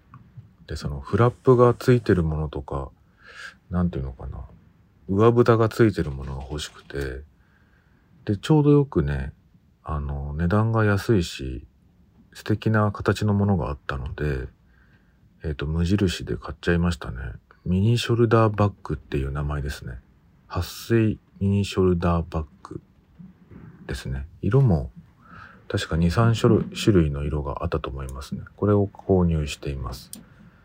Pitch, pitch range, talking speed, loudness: 90 Hz, 75-105 Hz, 285 characters per minute, -23 LUFS